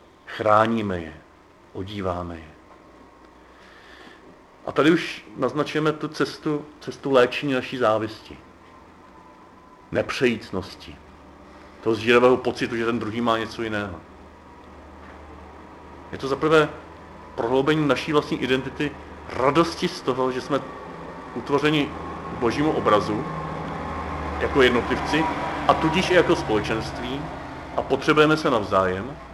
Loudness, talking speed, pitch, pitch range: -23 LUFS, 100 wpm, 115 Hz, 90-135 Hz